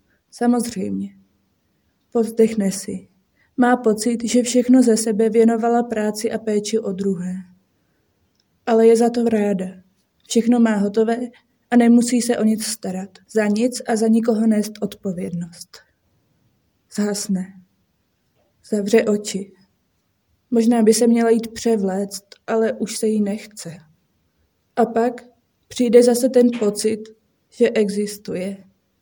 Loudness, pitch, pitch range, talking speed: -19 LUFS, 215 Hz, 190-230 Hz, 120 wpm